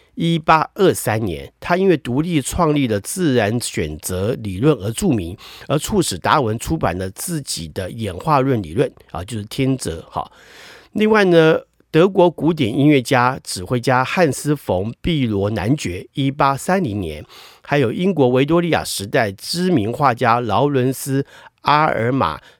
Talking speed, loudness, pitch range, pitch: 240 characters per minute, -18 LUFS, 105-160 Hz, 130 Hz